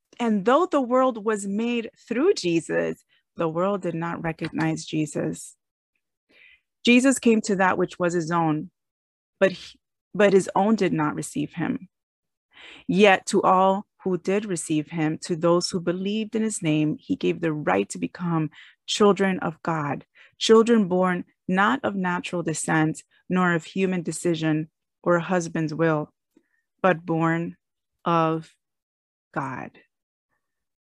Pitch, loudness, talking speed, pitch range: 180 Hz, -23 LUFS, 140 wpm, 160-205 Hz